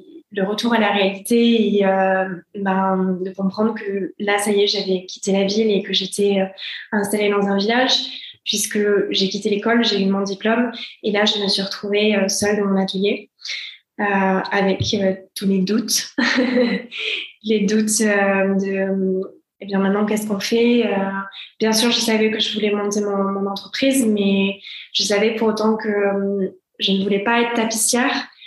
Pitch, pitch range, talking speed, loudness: 205 Hz, 195-225 Hz, 190 wpm, -19 LUFS